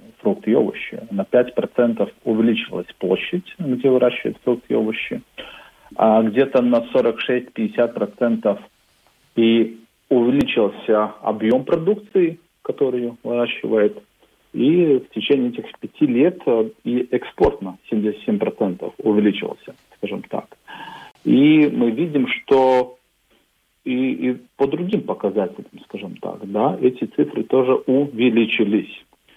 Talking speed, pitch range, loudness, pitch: 105 wpm, 110-130 Hz, -19 LUFS, 120 Hz